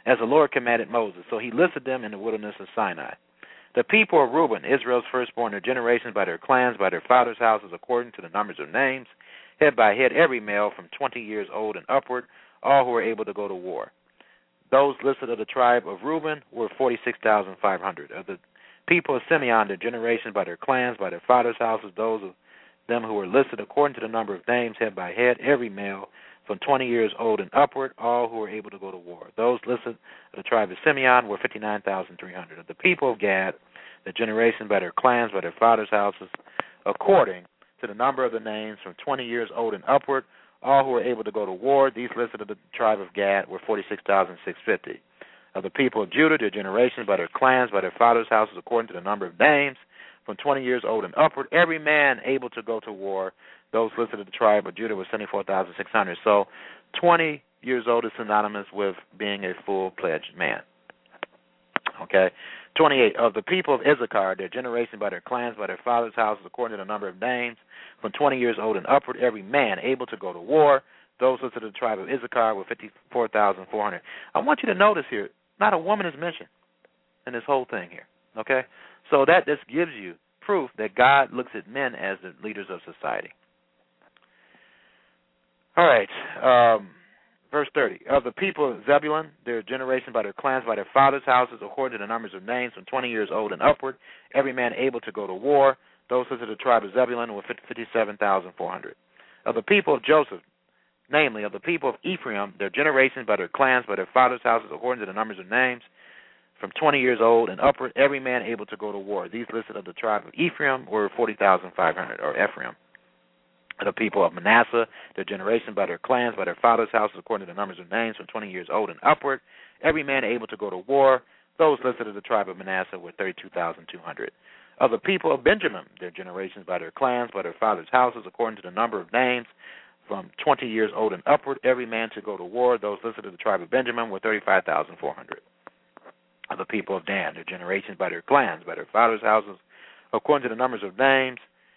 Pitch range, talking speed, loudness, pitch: 105-130 Hz, 210 wpm, -24 LUFS, 120 Hz